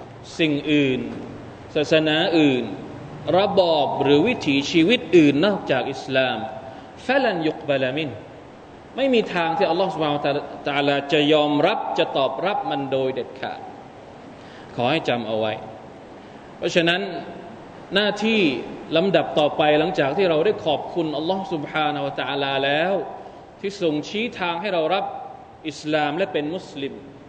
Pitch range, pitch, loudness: 140-175 Hz, 155 Hz, -21 LUFS